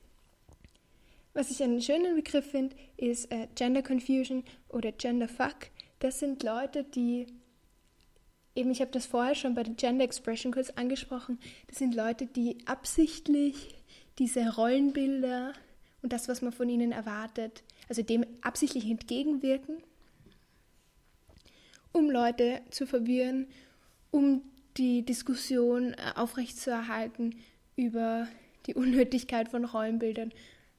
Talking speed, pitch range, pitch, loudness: 115 wpm, 235-265 Hz, 250 Hz, -32 LUFS